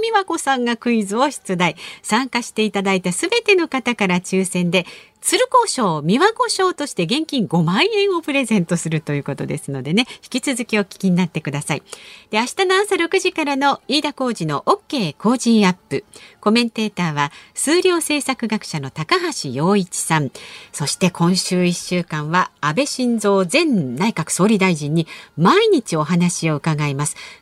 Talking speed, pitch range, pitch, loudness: 330 characters per minute, 175-285 Hz, 215 Hz, -18 LUFS